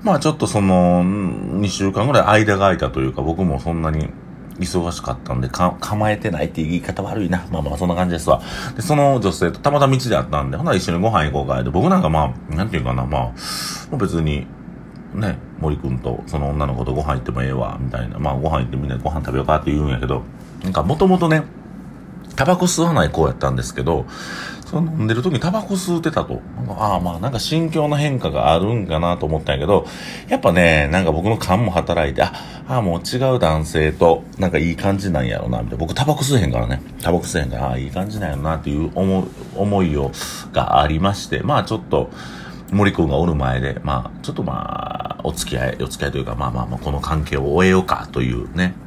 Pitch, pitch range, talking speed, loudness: 85 Hz, 70-100 Hz, 445 characters per minute, -19 LUFS